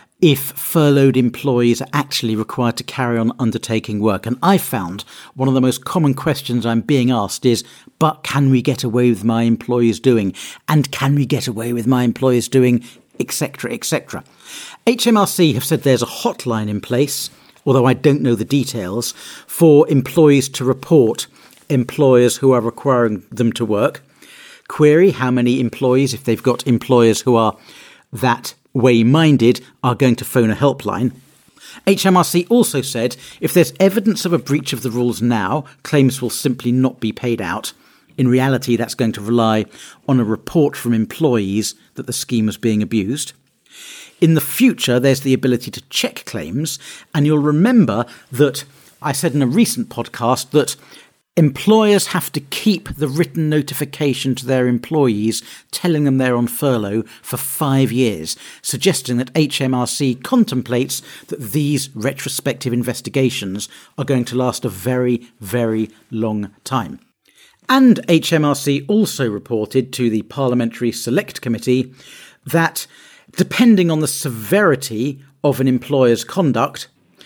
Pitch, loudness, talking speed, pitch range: 130 Hz, -17 LUFS, 155 wpm, 120-145 Hz